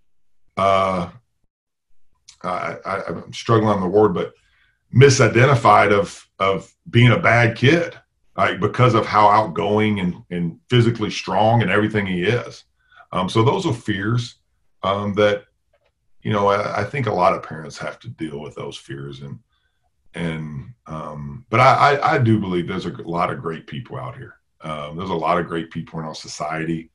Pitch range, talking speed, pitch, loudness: 85-115 Hz, 175 wpm, 100 Hz, -18 LUFS